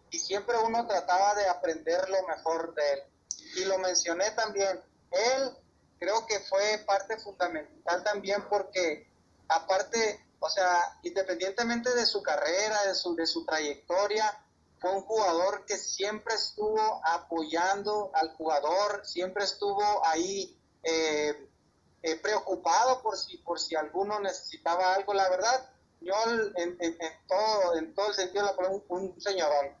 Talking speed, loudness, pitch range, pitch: 145 wpm, -30 LUFS, 170-210 Hz, 195 Hz